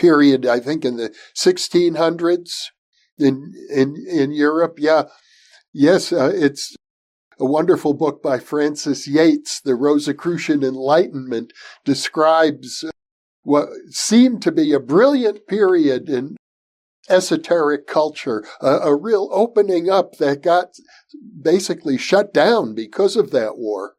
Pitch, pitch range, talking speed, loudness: 160 Hz, 145-200 Hz, 120 wpm, -18 LUFS